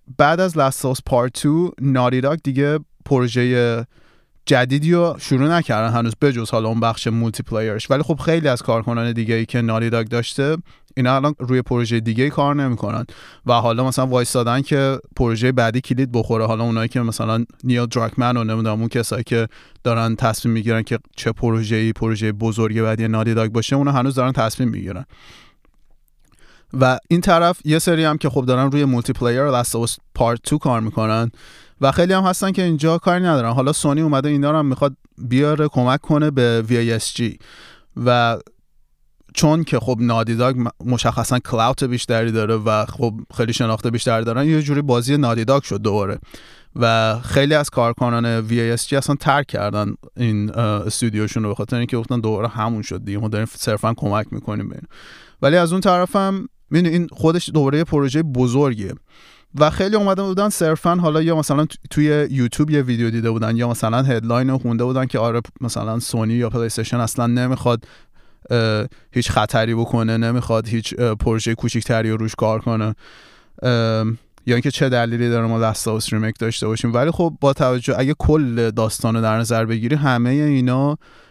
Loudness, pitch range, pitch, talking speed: -19 LUFS, 115-140 Hz, 120 Hz, 175 wpm